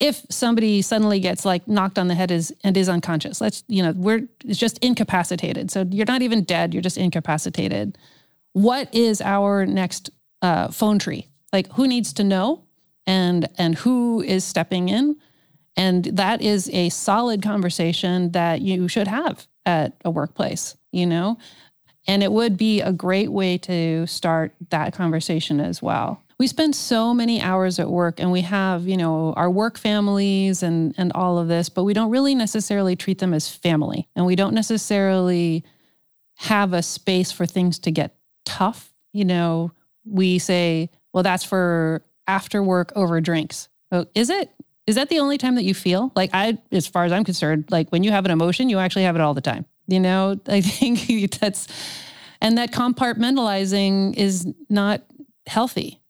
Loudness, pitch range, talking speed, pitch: -21 LUFS, 175-210 Hz, 180 wpm, 185 Hz